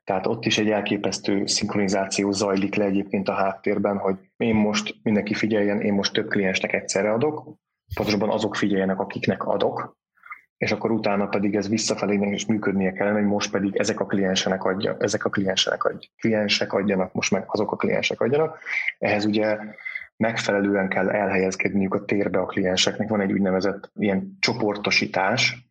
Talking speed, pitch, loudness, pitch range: 165 wpm, 100 Hz, -23 LUFS, 100-105 Hz